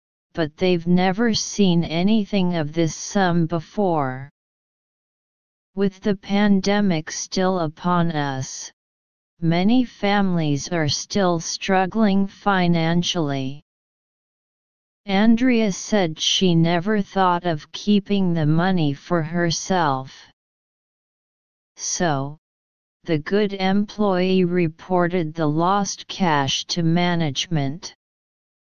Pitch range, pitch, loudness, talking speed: 155-195 Hz, 175 Hz, -21 LUFS, 90 wpm